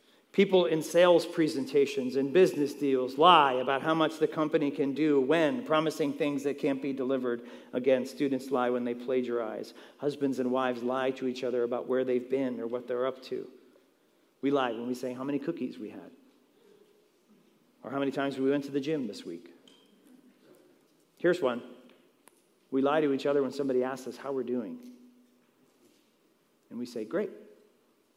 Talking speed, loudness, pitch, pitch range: 175 wpm, -29 LUFS, 140 Hz, 130-155 Hz